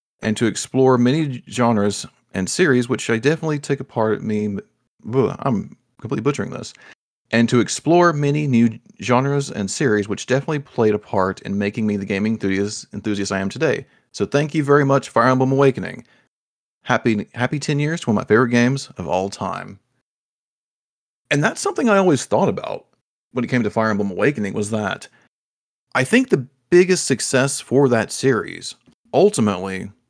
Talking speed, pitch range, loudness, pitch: 175 wpm, 105-140 Hz, -19 LUFS, 125 Hz